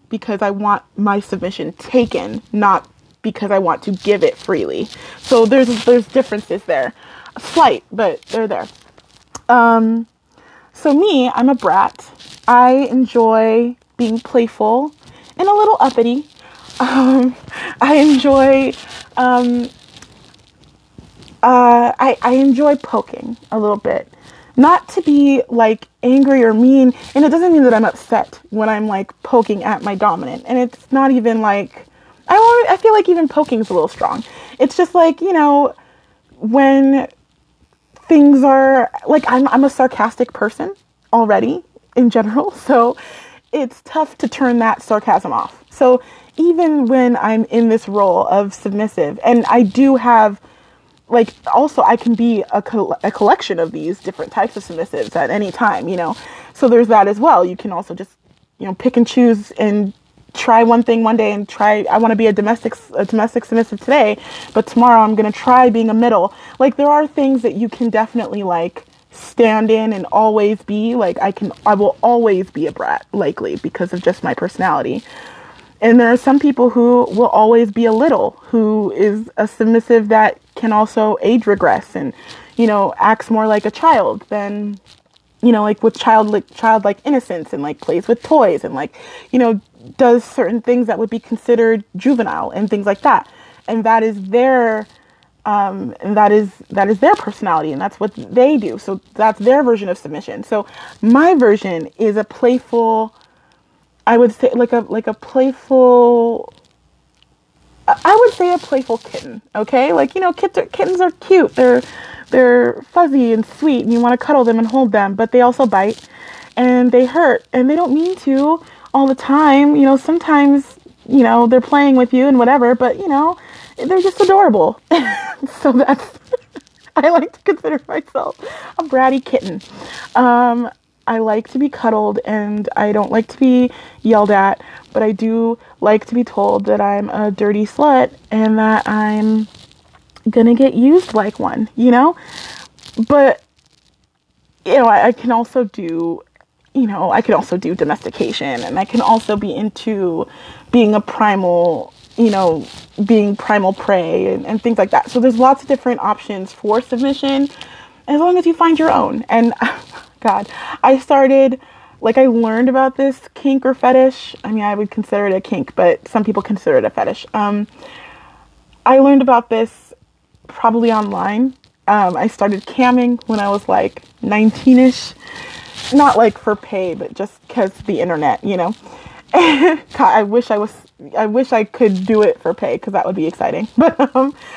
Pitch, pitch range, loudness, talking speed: 240 Hz, 215-270 Hz, -14 LUFS, 175 wpm